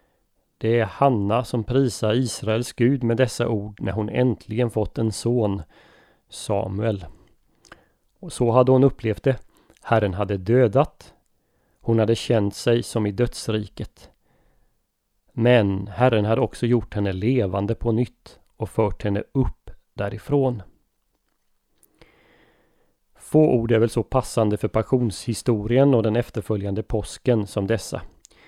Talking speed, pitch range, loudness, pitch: 130 wpm, 105-125 Hz, -22 LUFS, 115 Hz